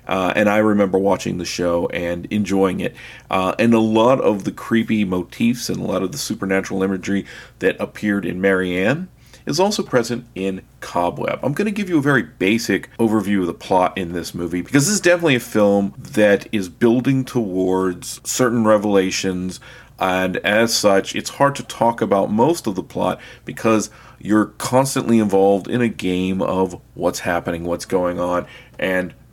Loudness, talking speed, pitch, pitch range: -19 LUFS, 180 wpm, 100 Hz, 95-115 Hz